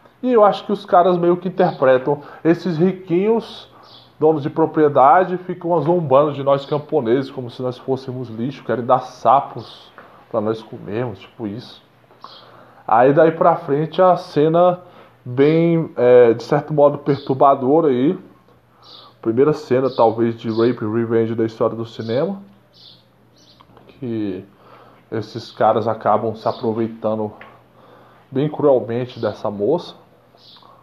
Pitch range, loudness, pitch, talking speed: 115-160 Hz, -17 LUFS, 130 Hz, 125 wpm